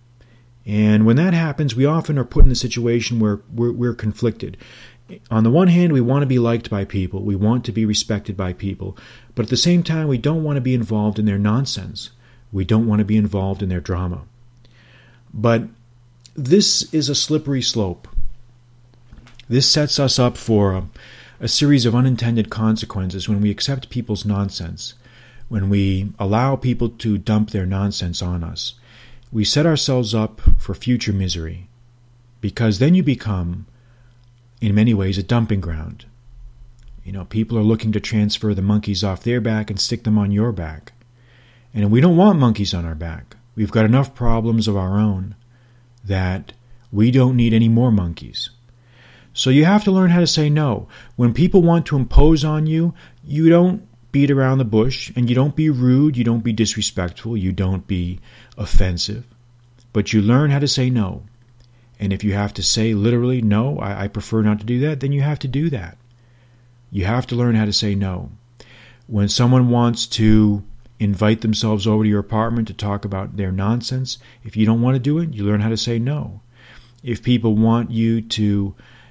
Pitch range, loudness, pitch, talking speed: 105-125 Hz, -18 LUFS, 115 Hz, 185 wpm